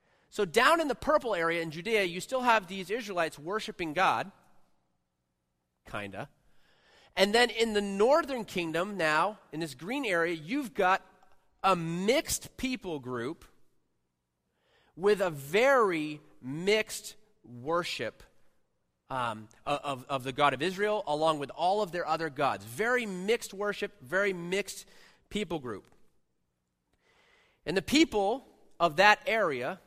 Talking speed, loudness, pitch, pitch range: 135 wpm, -29 LUFS, 180 Hz, 140-210 Hz